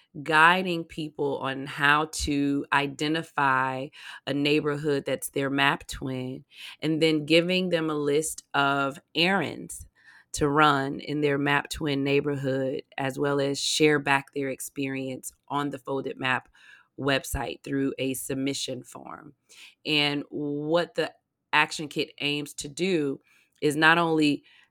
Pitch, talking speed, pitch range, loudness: 145 Hz, 130 wpm, 140-155 Hz, -26 LUFS